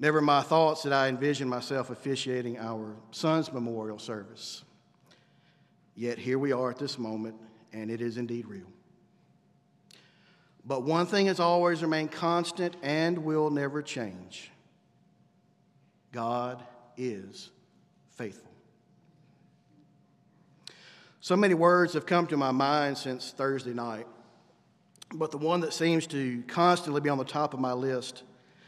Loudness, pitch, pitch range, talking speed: -29 LUFS, 135 Hz, 120-160 Hz, 135 wpm